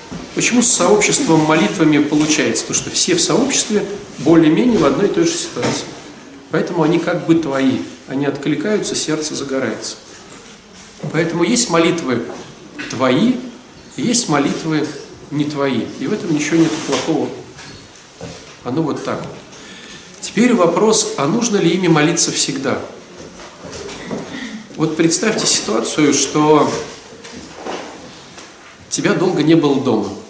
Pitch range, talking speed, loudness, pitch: 150-205 Hz, 120 wpm, -15 LUFS, 165 Hz